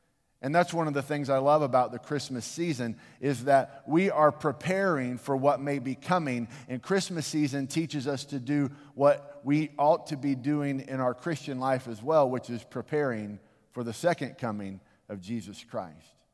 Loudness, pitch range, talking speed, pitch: -29 LUFS, 125-150 Hz, 185 wpm, 140 Hz